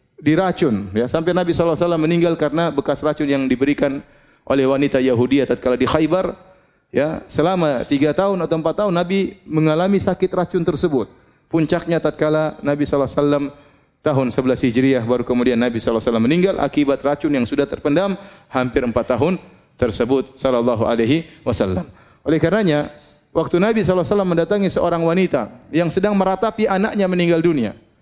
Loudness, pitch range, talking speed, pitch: -18 LUFS, 135-180 Hz, 145 wpm, 155 Hz